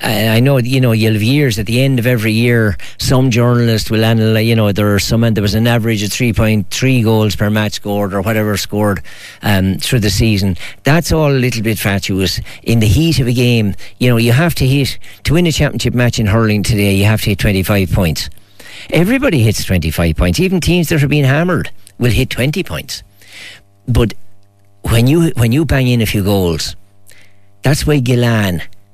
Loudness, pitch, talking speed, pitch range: -13 LUFS, 110 Hz, 205 wpm, 100-125 Hz